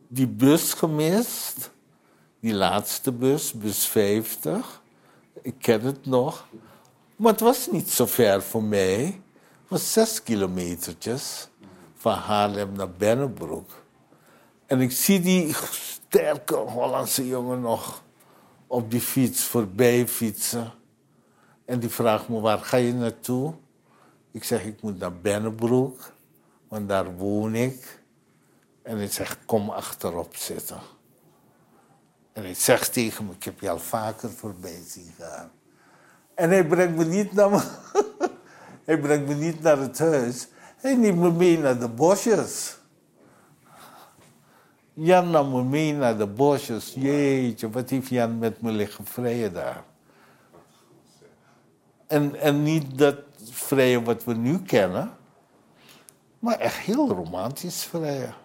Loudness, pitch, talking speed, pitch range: -24 LUFS, 125 Hz, 130 wpm, 110-150 Hz